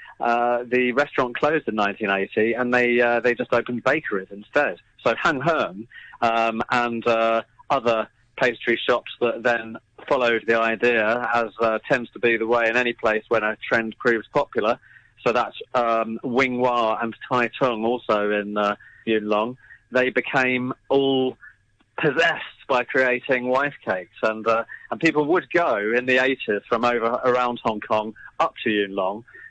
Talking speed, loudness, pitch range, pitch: 165 wpm, -22 LUFS, 110-125 Hz, 120 Hz